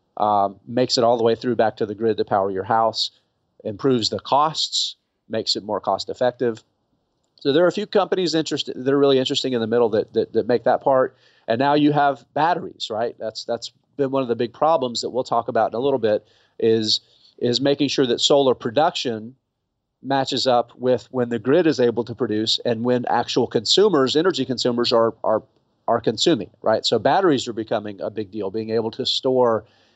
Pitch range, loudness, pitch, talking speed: 110-135 Hz, -21 LUFS, 120 Hz, 210 wpm